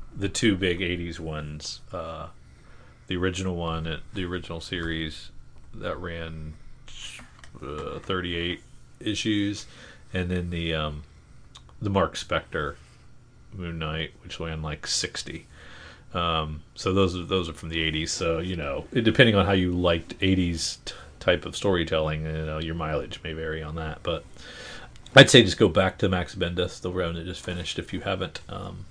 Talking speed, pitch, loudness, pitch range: 165 wpm, 85 Hz, -26 LUFS, 80-90 Hz